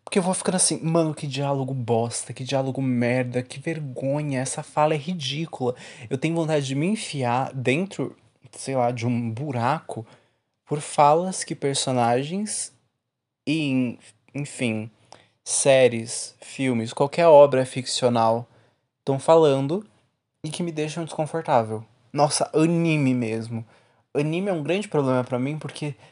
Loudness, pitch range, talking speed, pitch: -23 LUFS, 125-155 Hz, 135 wpm, 135 Hz